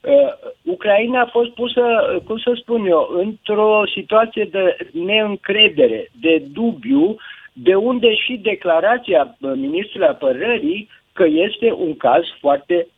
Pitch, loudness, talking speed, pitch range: 225 Hz, -17 LUFS, 125 wpm, 200-255 Hz